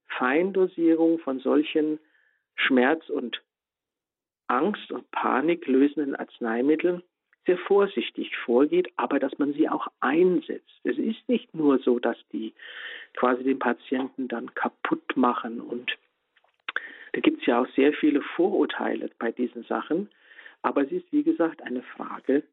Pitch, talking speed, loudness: 160 Hz, 135 wpm, -26 LUFS